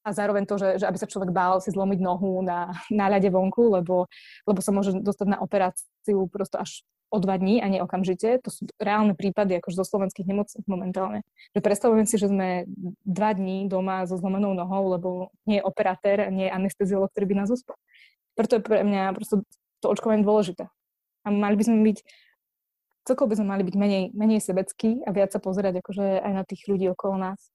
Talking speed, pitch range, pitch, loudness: 205 wpm, 190-210 Hz, 195 Hz, -25 LUFS